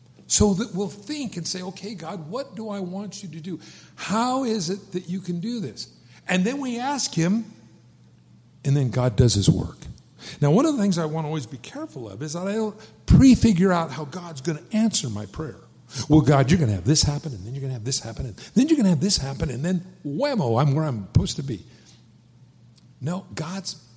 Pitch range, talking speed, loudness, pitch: 135-200 Hz, 235 wpm, -23 LUFS, 165 Hz